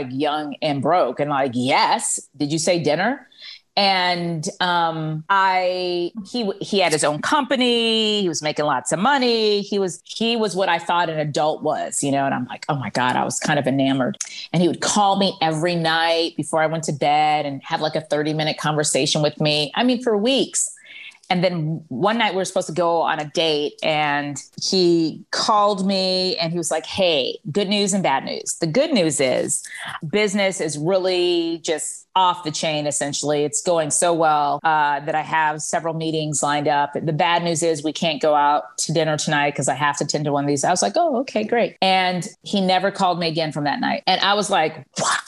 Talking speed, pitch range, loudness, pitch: 215 wpm, 150-195 Hz, -20 LUFS, 165 Hz